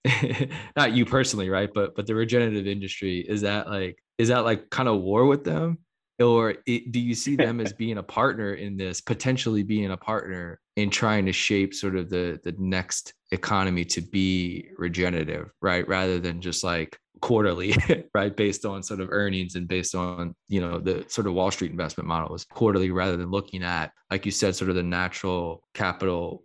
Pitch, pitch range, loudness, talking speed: 100 Hz, 90-110 Hz, -26 LUFS, 195 wpm